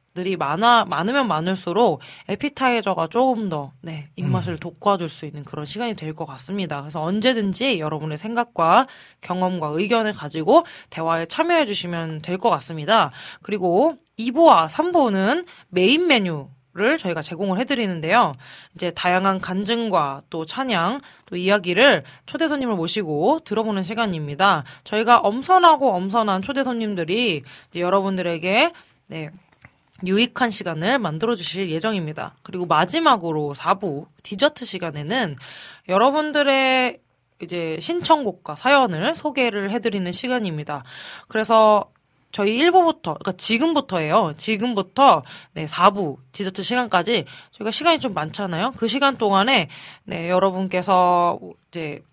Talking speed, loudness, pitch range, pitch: 315 characters per minute, -20 LUFS, 165-240 Hz, 195 Hz